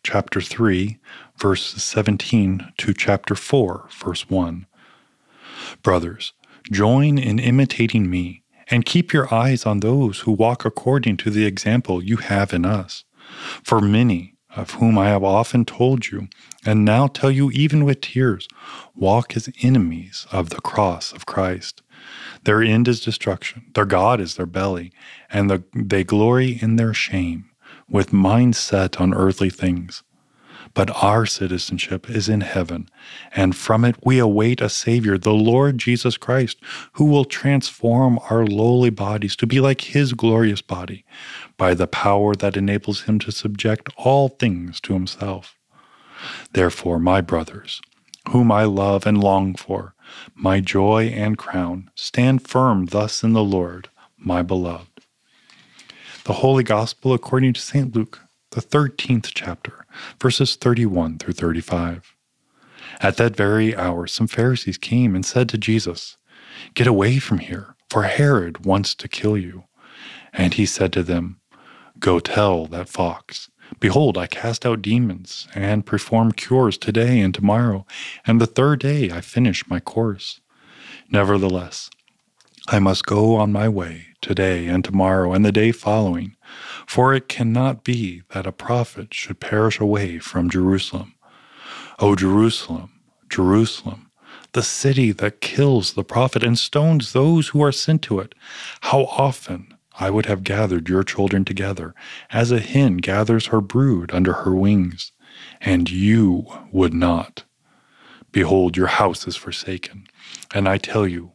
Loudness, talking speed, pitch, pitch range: -19 LUFS, 150 wpm, 105 Hz, 95-120 Hz